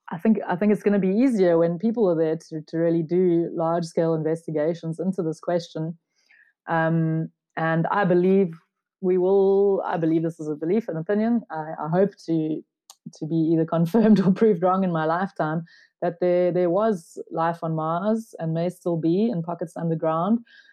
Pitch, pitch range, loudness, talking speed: 170 Hz, 165-195 Hz, -23 LUFS, 185 wpm